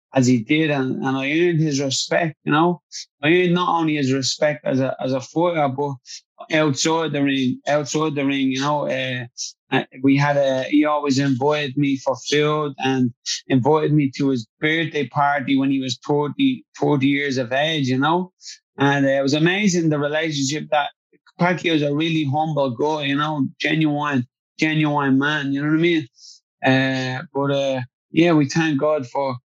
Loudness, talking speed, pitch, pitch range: -20 LUFS, 180 wpm, 145 Hz, 135-155 Hz